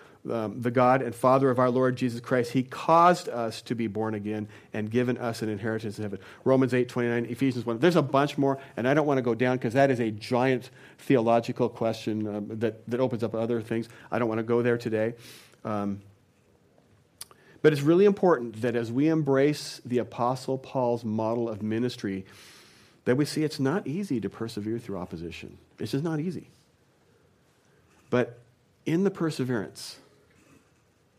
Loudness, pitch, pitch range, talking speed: -27 LUFS, 120 Hz, 110-130 Hz, 185 wpm